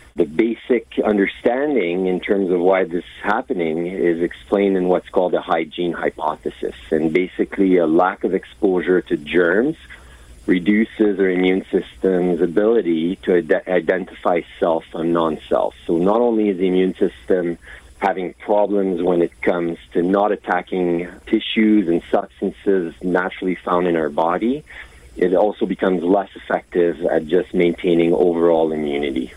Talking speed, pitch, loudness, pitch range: 145 wpm, 90 Hz, -19 LUFS, 85-95 Hz